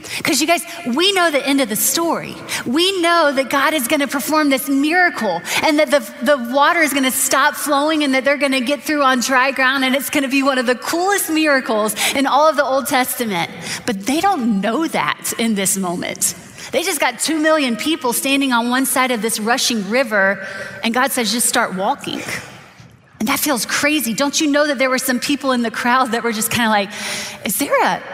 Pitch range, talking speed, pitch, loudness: 240-295 Hz, 230 wpm, 270 Hz, -16 LUFS